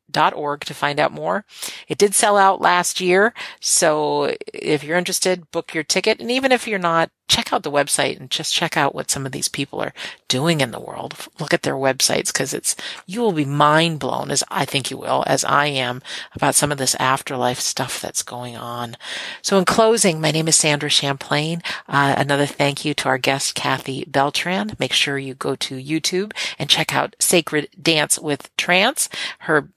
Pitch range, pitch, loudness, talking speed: 135-180 Hz, 150 Hz, -19 LUFS, 205 wpm